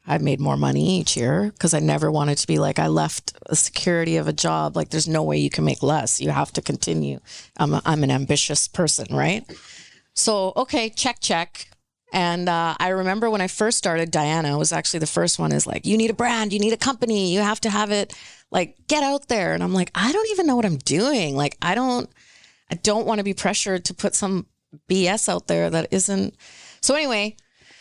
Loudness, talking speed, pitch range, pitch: -21 LUFS, 225 wpm, 150-215 Hz, 185 Hz